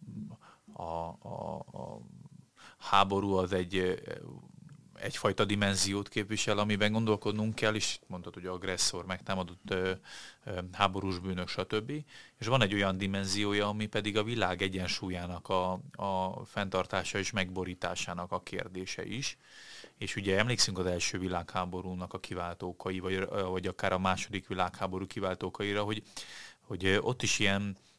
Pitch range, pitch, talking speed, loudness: 90-105 Hz, 95 Hz, 125 wpm, -33 LUFS